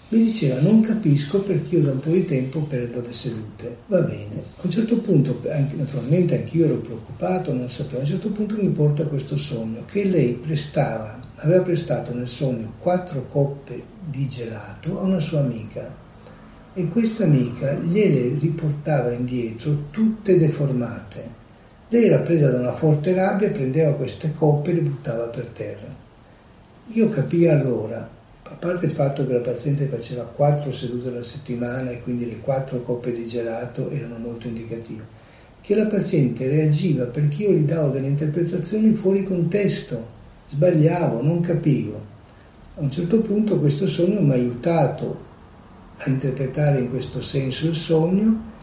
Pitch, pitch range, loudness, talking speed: 145 Hz, 120-170 Hz, -22 LUFS, 160 wpm